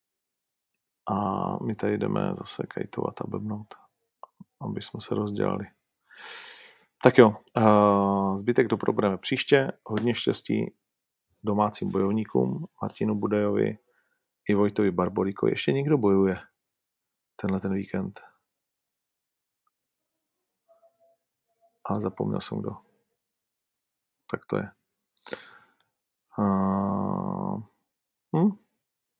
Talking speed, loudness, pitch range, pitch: 85 wpm, -26 LUFS, 100-155 Hz, 105 Hz